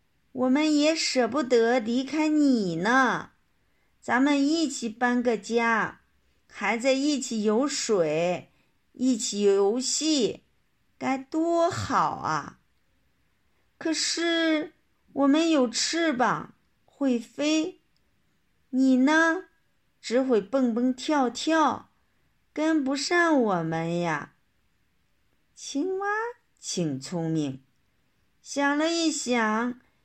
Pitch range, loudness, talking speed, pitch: 230-310 Hz, -25 LUFS, 125 characters per minute, 265 Hz